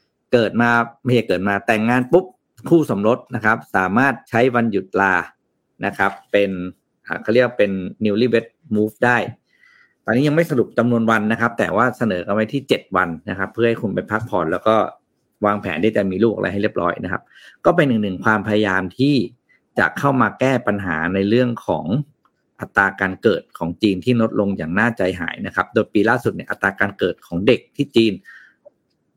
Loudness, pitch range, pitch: -19 LUFS, 100-120 Hz, 110 Hz